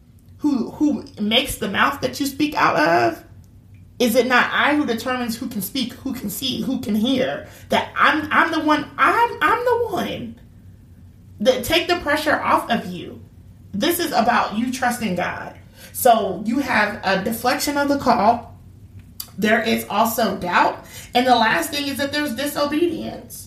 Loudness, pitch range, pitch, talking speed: -19 LUFS, 205-285 Hz, 245 Hz, 170 wpm